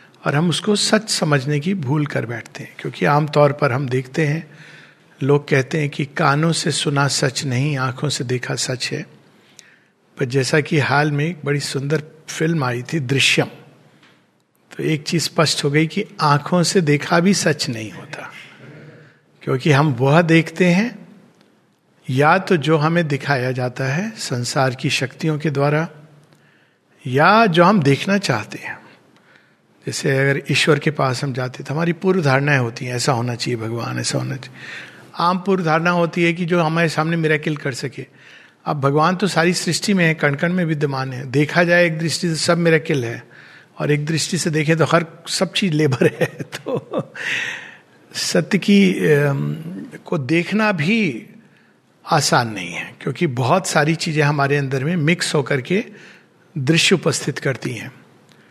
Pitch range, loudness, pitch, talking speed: 140-175 Hz, -18 LUFS, 155 Hz, 165 wpm